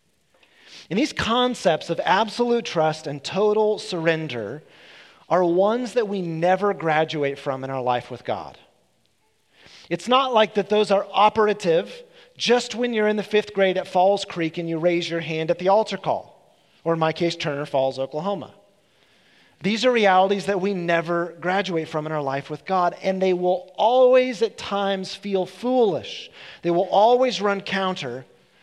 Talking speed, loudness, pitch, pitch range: 170 wpm, -22 LUFS, 190 Hz, 165-210 Hz